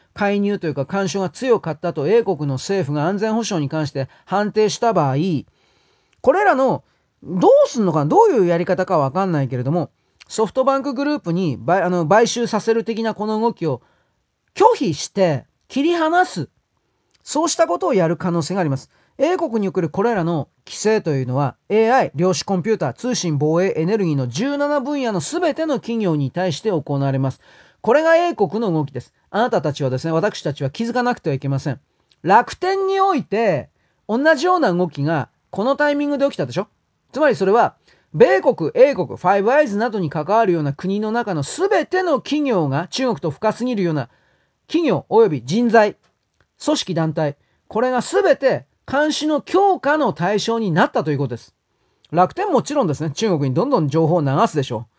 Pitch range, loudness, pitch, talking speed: 155-250 Hz, -19 LUFS, 195 Hz, 365 characters per minute